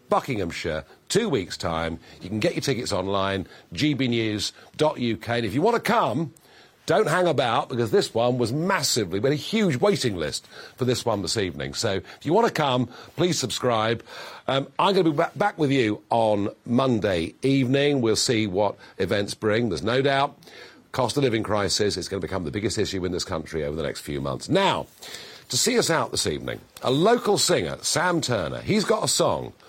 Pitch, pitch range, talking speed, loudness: 125 Hz, 110-145 Hz, 200 wpm, -24 LUFS